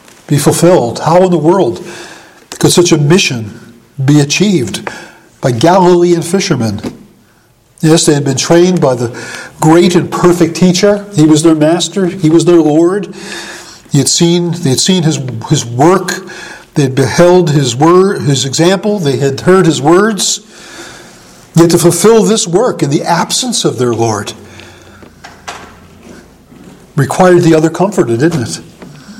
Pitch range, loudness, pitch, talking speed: 135-180 Hz, -9 LUFS, 165 Hz, 150 wpm